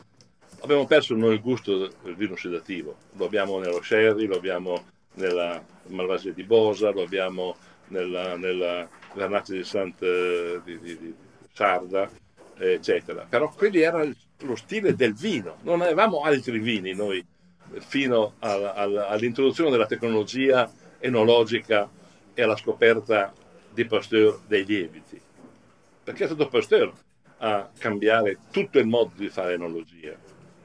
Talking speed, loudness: 135 wpm, -24 LUFS